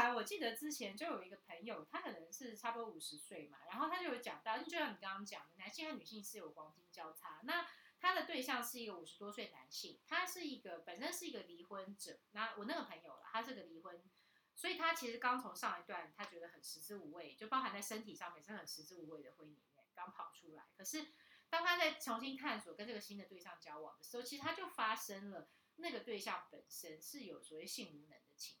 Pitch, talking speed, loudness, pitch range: 220 Hz, 350 characters per minute, -45 LUFS, 175-265 Hz